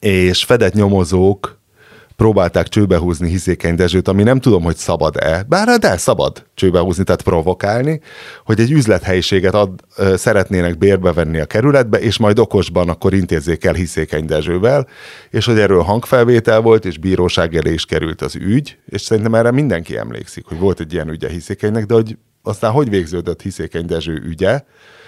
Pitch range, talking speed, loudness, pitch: 85-110 Hz, 160 wpm, -14 LUFS, 95 Hz